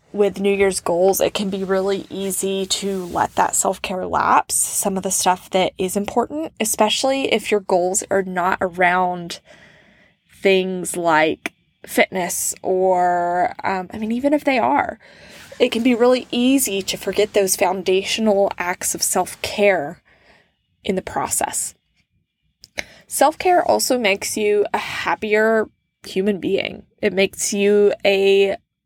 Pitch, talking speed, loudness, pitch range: 195 Hz, 145 wpm, -19 LUFS, 185-215 Hz